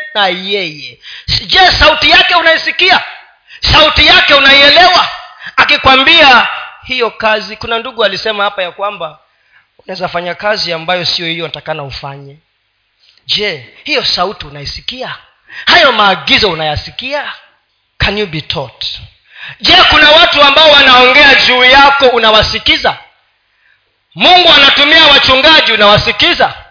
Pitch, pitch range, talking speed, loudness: 225 Hz, 175-290 Hz, 95 wpm, -6 LUFS